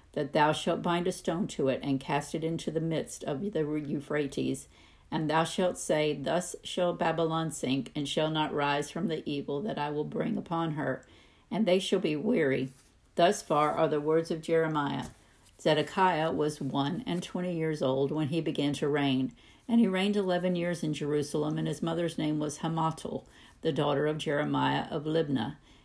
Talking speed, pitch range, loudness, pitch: 190 wpm, 145-170 Hz, -30 LUFS, 155 Hz